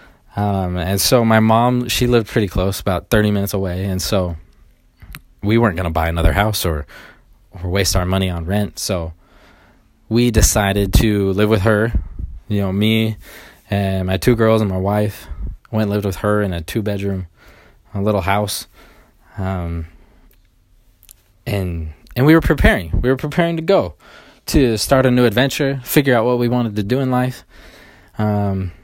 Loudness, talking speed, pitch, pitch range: -17 LUFS, 175 wpm, 100 Hz, 95-115 Hz